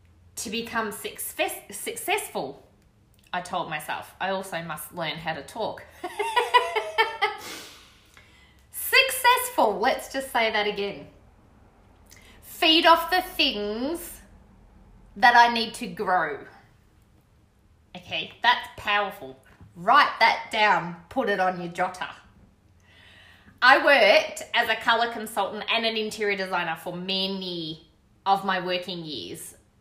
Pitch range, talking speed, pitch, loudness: 160-270 Hz, 115 wpm, 205 Hz, -24 LUFS